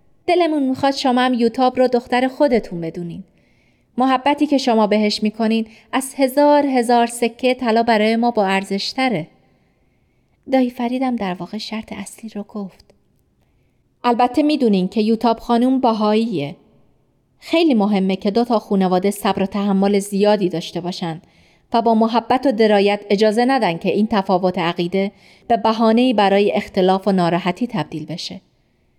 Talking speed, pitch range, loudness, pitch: 140 wpm, 195-245 Hz, -18 LUFS, 220 Hz